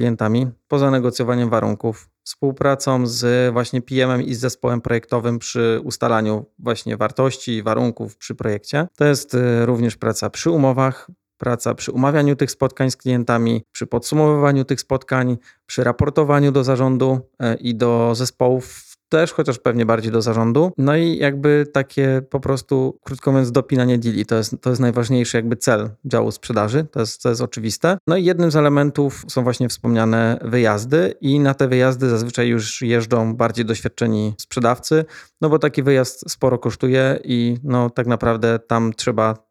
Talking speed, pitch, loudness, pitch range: 155 wpm, 125 Hz, -19 LUFS, 115-135 Hz